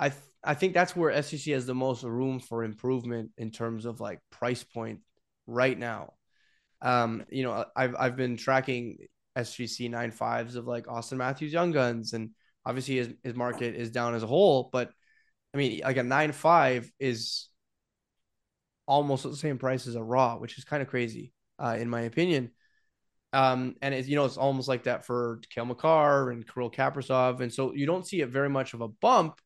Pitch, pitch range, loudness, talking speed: 125 Hz, 115-135 Hz, -29 LUFS, 195 wpm